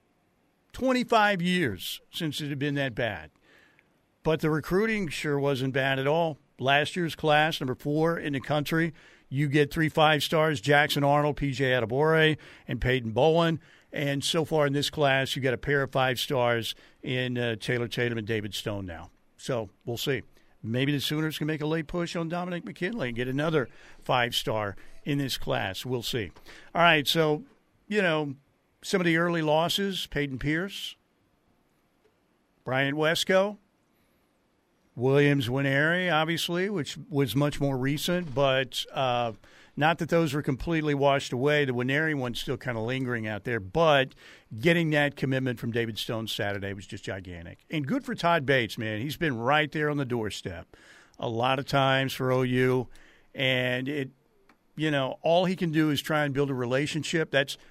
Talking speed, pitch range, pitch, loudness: 175 wpm, 125-160 Hz, 140 Hz, -27 LUFS